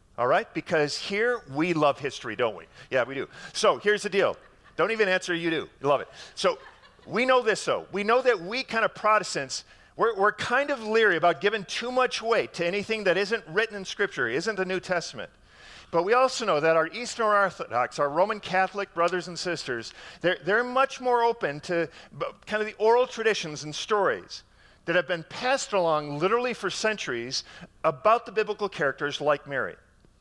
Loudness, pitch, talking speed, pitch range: -26 LUFS, 200 Hz, 195 wpm, 170-225 Hz